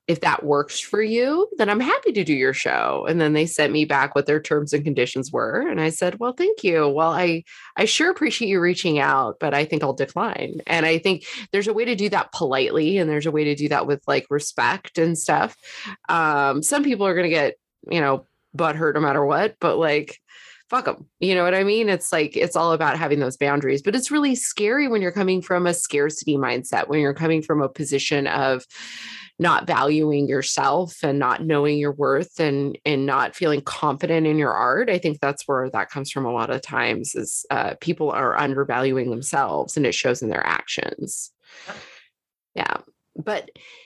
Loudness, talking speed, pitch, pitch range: -21 LUFS, 210 wpm, 155 Hz, 140-180 Hz